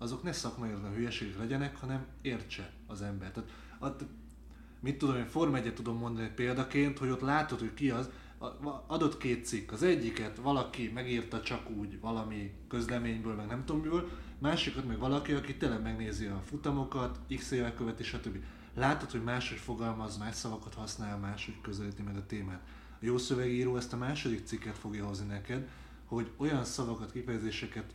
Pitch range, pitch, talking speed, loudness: 110-130 Hz, 120 Hz, 165 wpm, -36 LUFS